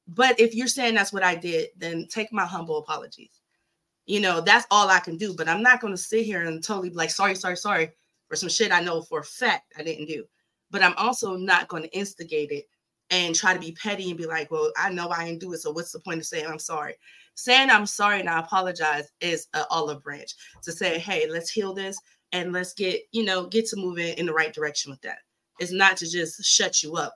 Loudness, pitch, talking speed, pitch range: -24 LUFS, 180 Hz, 255 wpm, 165-205 Hz